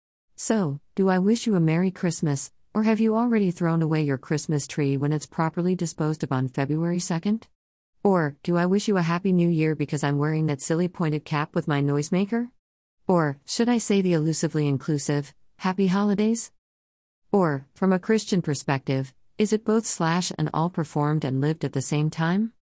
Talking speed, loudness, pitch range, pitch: 190 wpm, -24 LUFS, 145-190 Hz, 165 Hz